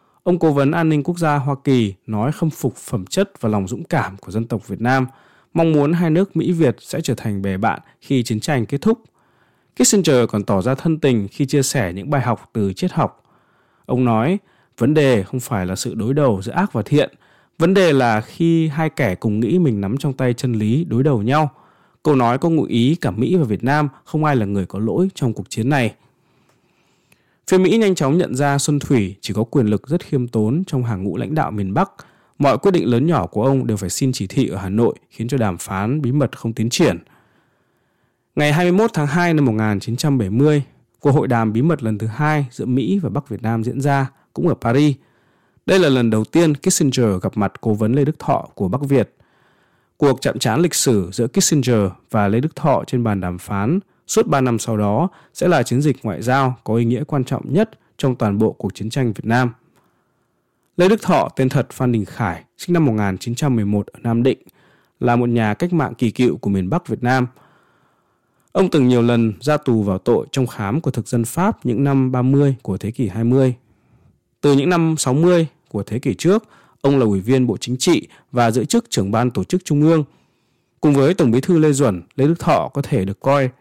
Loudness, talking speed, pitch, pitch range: -18 LUFS, 230 wpm, 130 Hz, 115-150 Hz